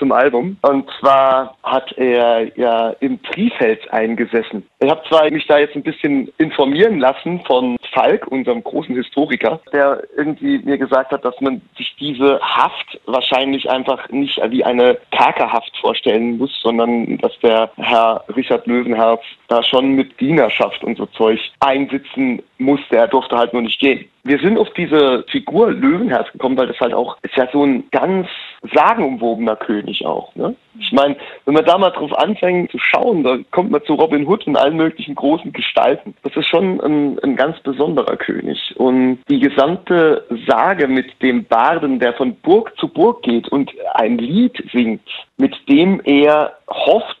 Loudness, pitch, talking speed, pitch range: -15 LUFS, 140 Hz, 175 wpm, 125-170 Hz